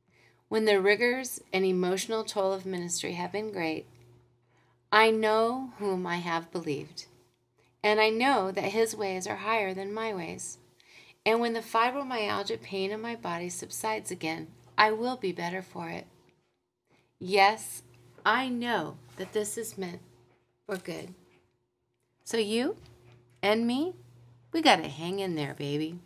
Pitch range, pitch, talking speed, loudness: 145-220 Hz, 190 Hz, 145 wpm, -29 LUFS